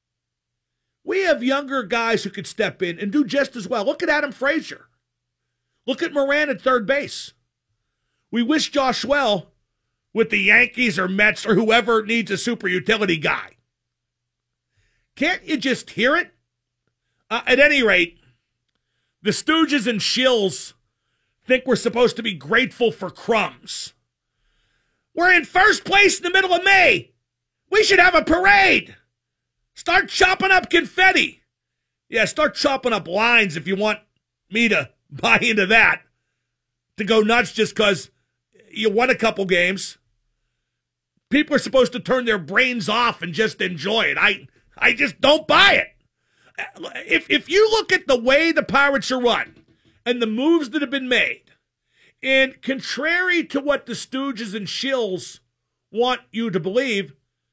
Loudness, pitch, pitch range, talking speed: -18 LUFS, 230 Hz, 185-280 Hz, 155 wpm